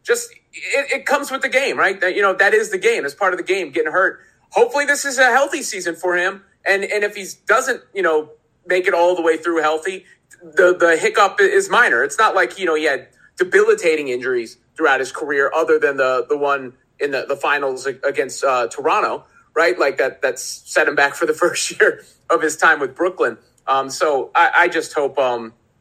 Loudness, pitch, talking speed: -17 LUFS, 195 Hz, 225 wpm